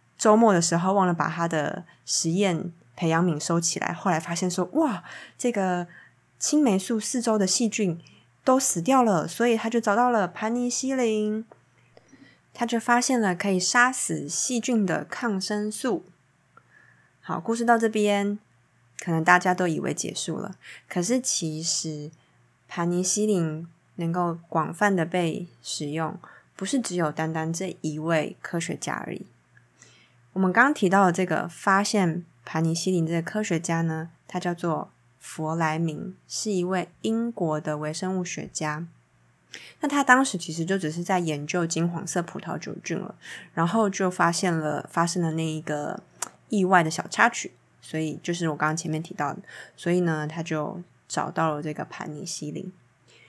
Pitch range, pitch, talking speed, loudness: 160-205 Hz, 175 Hz, 240 characters per minute, -25 LUFS